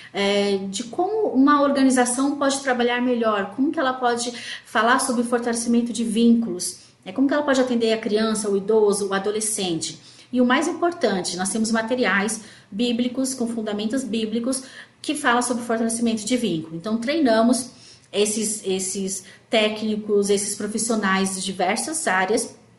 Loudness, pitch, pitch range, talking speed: -22 LUFS, 230 Hz, 200-250 Hz, 145 wpm